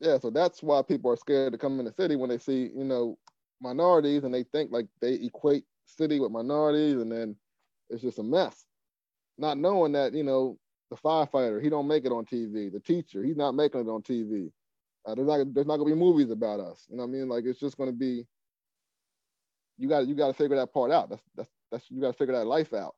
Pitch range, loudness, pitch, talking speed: 120-150 Hz, -28 LUFS, 135 Hz, 245 wpm